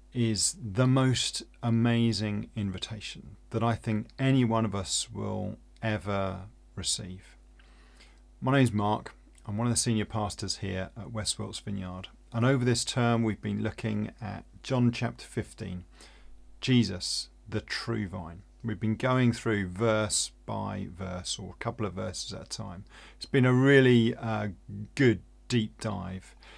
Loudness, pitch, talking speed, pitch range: -29 LUFS, 110 Hz, 150 wpm, 95-115 Hz